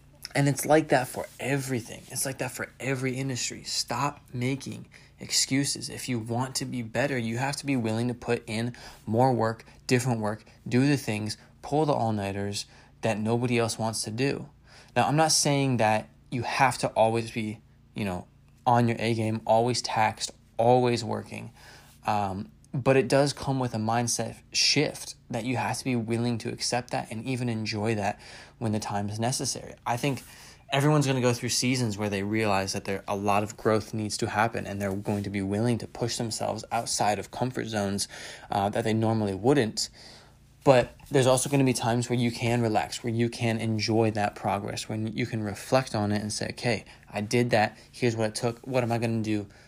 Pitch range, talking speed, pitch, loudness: 110-125 Hz, 200 wpm, 120 Hz, -27 LUFS